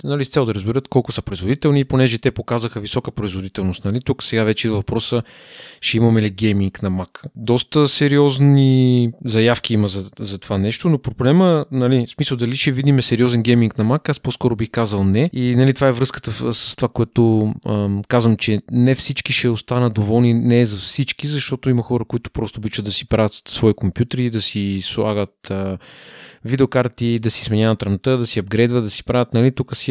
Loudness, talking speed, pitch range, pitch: -18 LUFS, 200 wpm, 110-130 Hz, 120 Hz